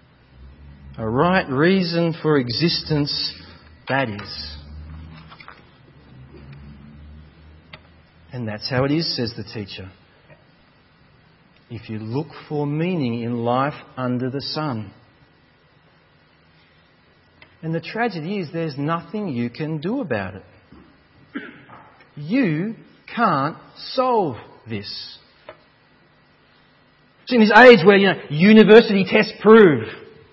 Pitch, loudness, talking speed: 130 Hz, -18 LUFS, 100 wpm